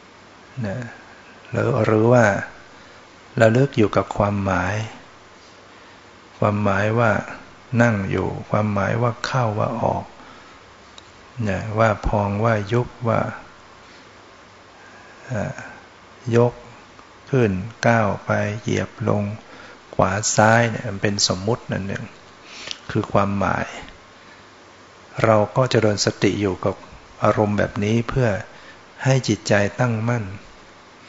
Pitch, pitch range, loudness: 110 Hz, 100-115 Hz, -21 LUFS